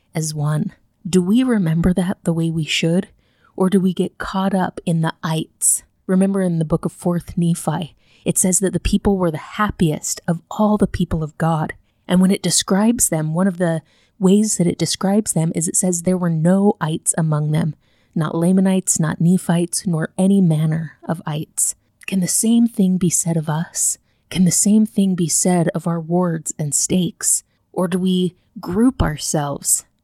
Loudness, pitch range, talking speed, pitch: -18 LUFS, 160-190 Hz, 190 wpm, 175 Hz